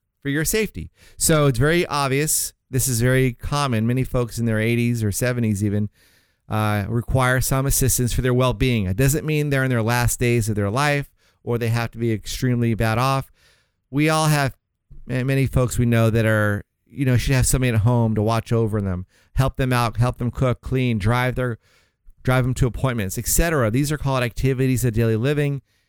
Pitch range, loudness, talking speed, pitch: 110-135 Hz, -21 LUFS, 200 wpm, 125 Hz